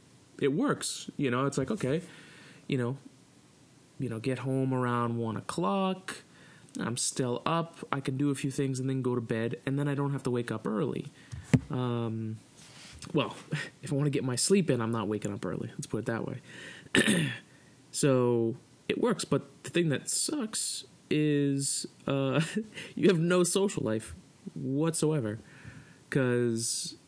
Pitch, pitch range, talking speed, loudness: 140 Hz, 125-155 Hz, 170 wpm, -31 LUFS